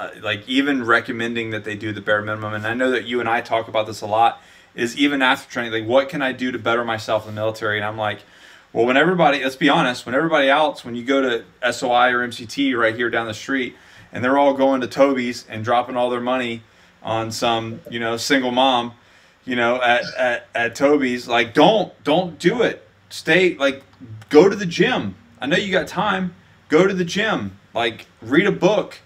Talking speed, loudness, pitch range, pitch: 225 wpm, -19 LUFS, 110-135 Hz, 120 Hz